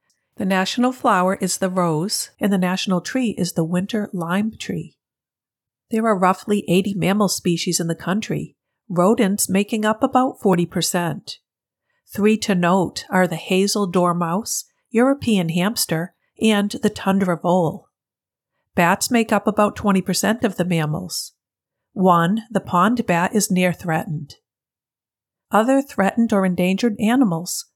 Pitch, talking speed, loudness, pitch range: 190 Hz, 135 wpm, -20 LUFS, 175-215 Hz